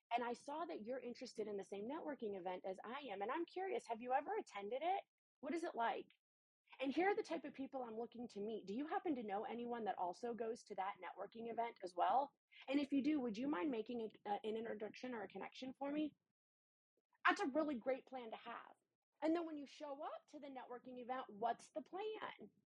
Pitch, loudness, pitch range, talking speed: 255 Hz, -45 LUFS, 225-300 Hz, 235 wpm